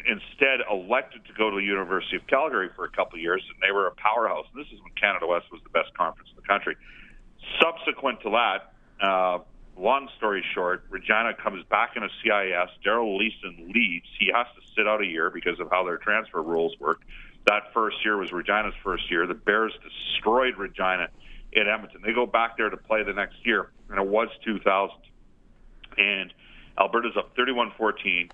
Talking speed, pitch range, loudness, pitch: 195 wpm, 90-115 Hz, -25 LUFS, 100 Hz